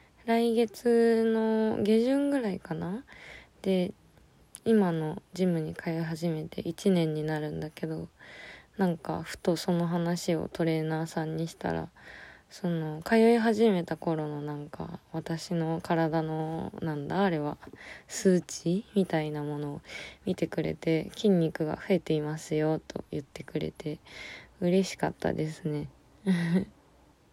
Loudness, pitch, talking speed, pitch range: -30 LUFS, 165 Hz, 240 characters per minute, 155-195 Hz